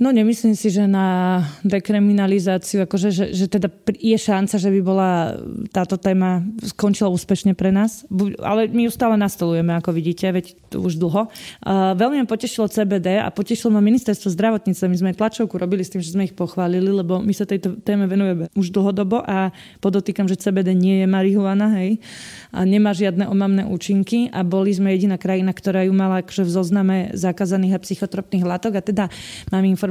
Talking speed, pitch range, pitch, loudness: 180 wpm, 185-205 Hz, 195 Hz, -19 LUFS